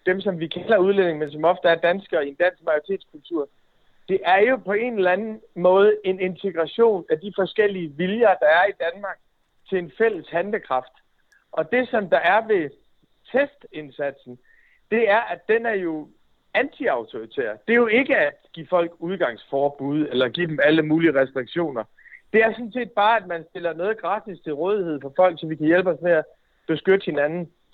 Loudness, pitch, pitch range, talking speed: -22 LUFS, 180 Hz, 160-220 Hz, 190 wpm